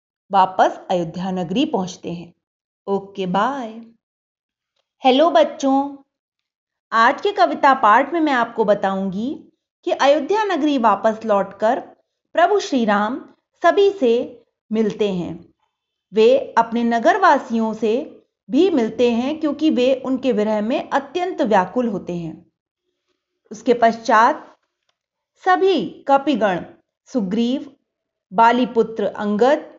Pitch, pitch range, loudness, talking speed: 245 Hz, 215-305 Hz, -18 LUFS, 110 wpm